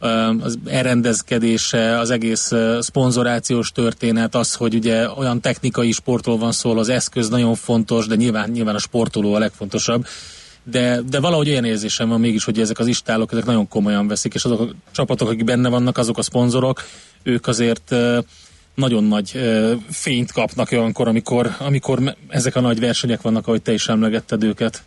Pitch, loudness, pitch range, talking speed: 115 Hz, -18 LUFS, 115-125 Hz, 165 wpm